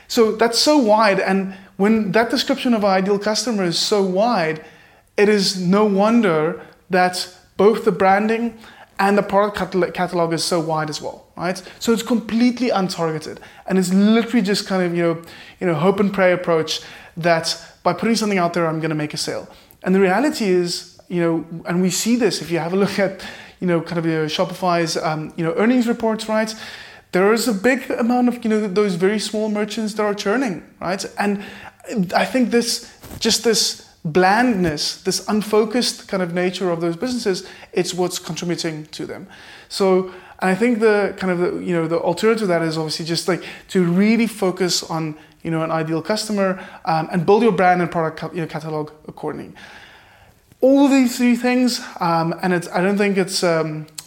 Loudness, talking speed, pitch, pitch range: -19 LUFS, 200 wpm, 190 Hz, 170-220 Hz